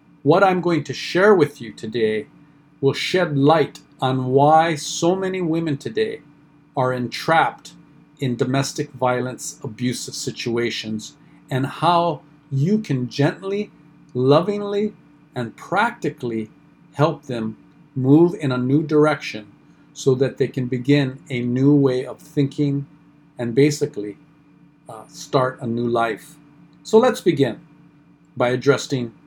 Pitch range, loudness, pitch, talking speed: 130-155 Hz, -20 LUFS, 145 Hz, 125 wpm